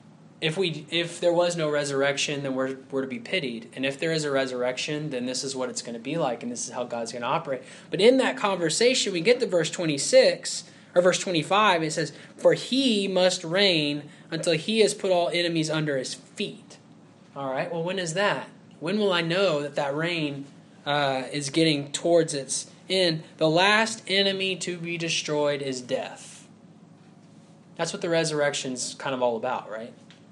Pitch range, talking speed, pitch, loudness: 145-185 Hz, 195 wpm, 165 Hz, -25 LUFS